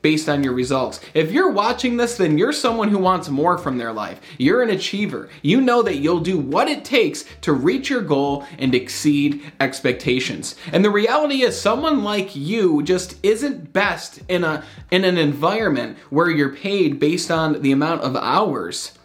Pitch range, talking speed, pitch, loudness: 145-215 Hz, 185 wpm, 175 Hz, -19 LUFS